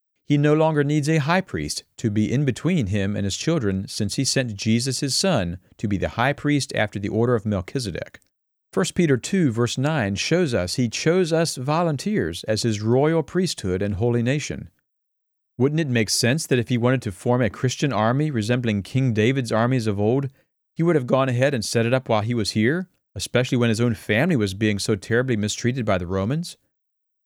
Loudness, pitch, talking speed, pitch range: -22 LUFS, 125 Hz, 205 wpm, 110-145 Hz